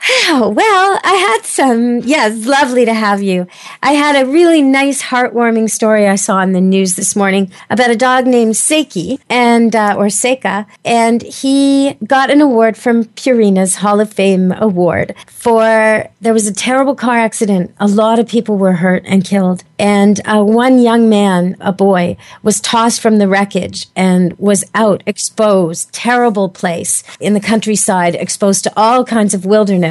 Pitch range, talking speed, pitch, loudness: 195-245 Hz, 175 wpm, 220 Hz, -11 LUFS